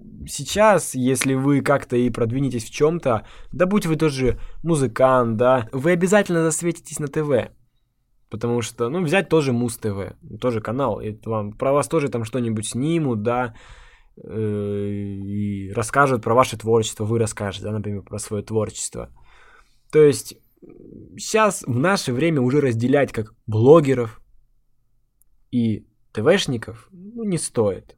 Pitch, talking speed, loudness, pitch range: 120 Hz, 135 wpm, -21 LUFS, 110-145 Hz